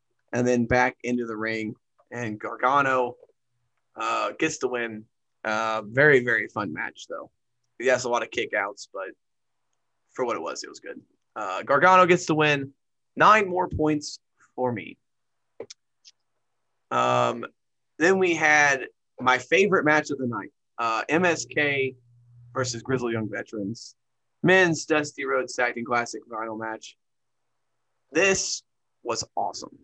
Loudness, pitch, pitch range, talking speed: -24 LUFS, 125 Hz, 120-150 Hz, 140 wpm